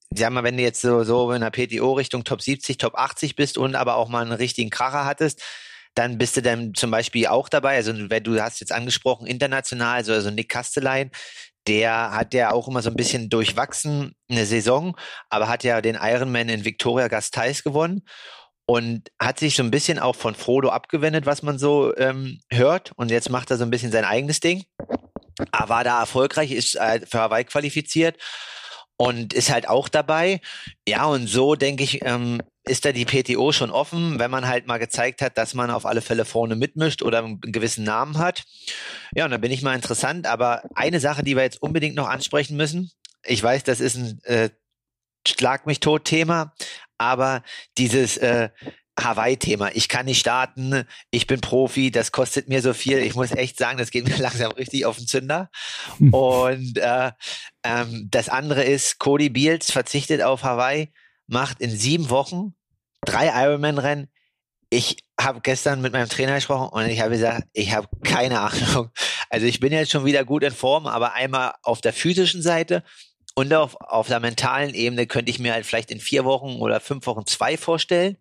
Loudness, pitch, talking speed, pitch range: -22 LUFS, 130 Hz, 190 wpm, 115-140 Hz